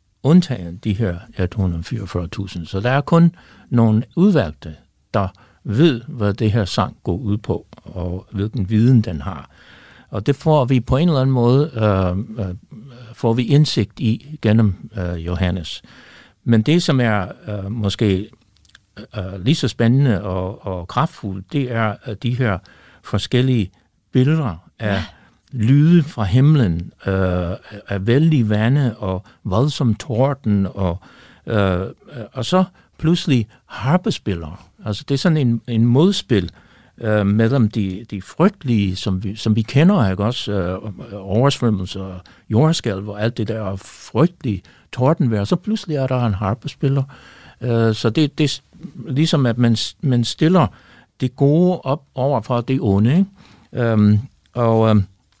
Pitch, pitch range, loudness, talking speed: 115 Hz, 100-135 Hz, -19 LUFS, 145 wpm